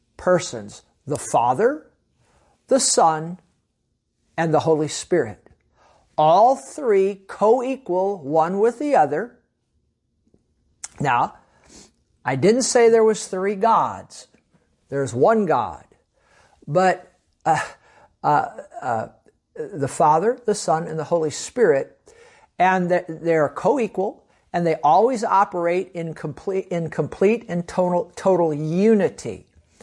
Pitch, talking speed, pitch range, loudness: 185 Hz, 110 wpm, 165-230 Hz, -20 LUFS